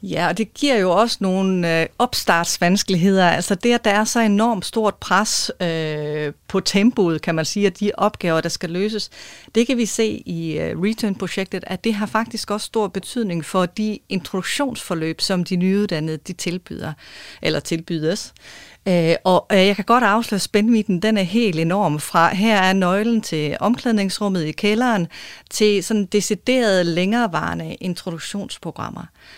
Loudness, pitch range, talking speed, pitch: -19 LUFS, 175-215 Hz, 160 wpm, 195 Hz